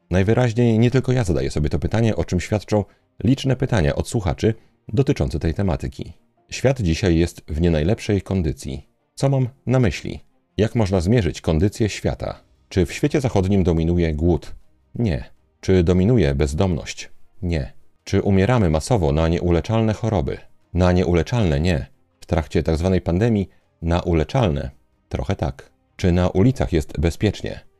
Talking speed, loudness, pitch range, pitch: 145 wpm, -20 LUFS, 85-115 Hz, 95 Hz